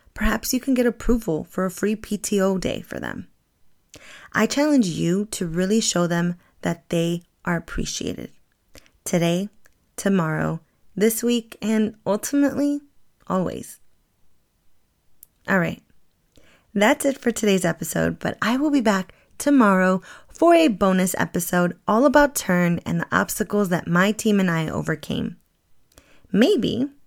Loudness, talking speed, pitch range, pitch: -22 LUFS, 135 wpm, 175-235 Hz, 205 Hz